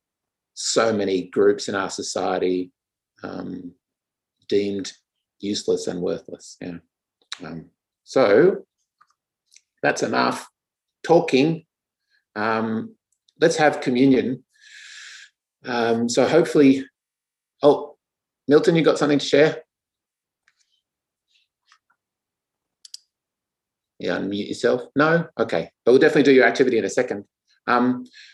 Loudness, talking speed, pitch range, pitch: -20 LUFS, 95 wpm, 110-160 Hz, 135 Hz